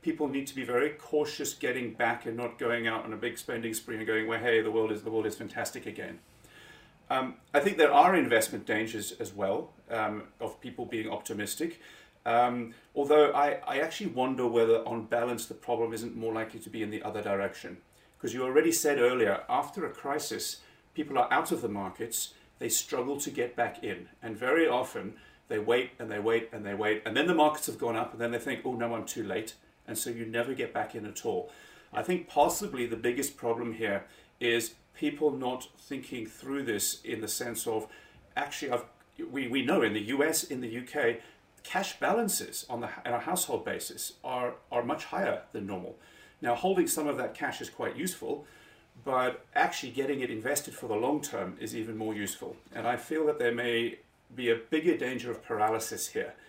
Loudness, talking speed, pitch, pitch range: -31 LUFS, 210 wpm, 120 Hz, 115-140 Hz